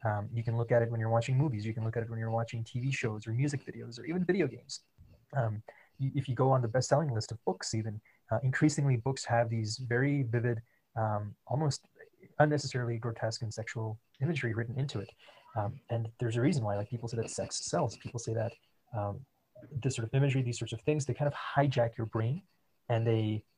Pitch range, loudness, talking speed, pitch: 115-135 Hz, -33 LUFS, 225 wpm, 120 Hz